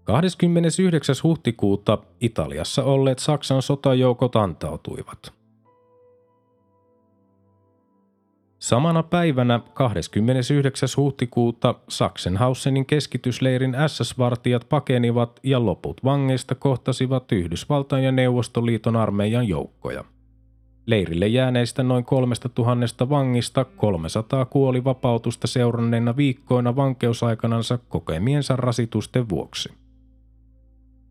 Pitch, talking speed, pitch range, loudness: 125 Hz, 75 wpm, 115-135 Hz, -22 LUFS